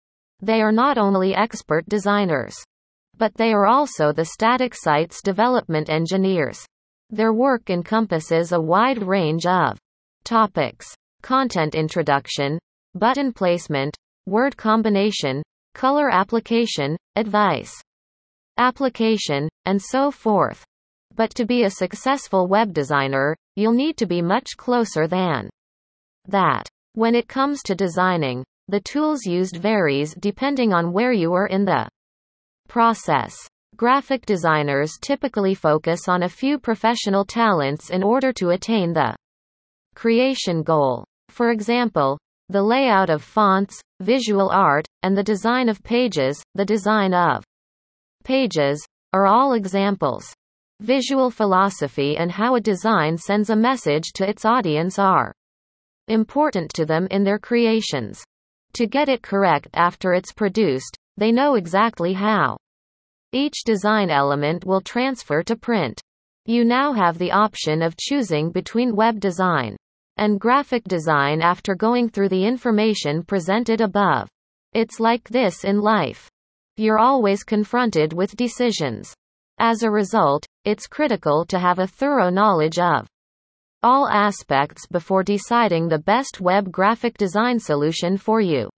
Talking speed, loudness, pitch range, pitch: 130 wpm, -20 LUFS, 165-230 Hz, 200 Hz